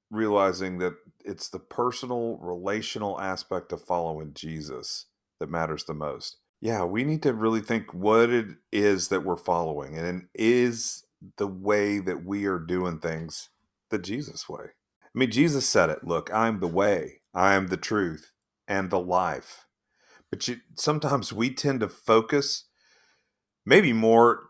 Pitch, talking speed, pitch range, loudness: 100 Hz, 155 wpm, 90-115 Hz, -26 LUFS